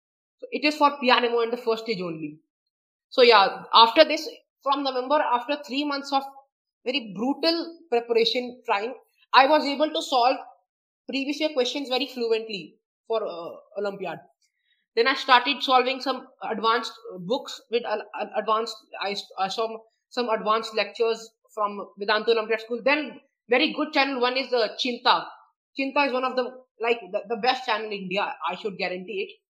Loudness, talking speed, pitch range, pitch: -24 LUFS, 165 wpm, 225-275 Hz, 250 Hz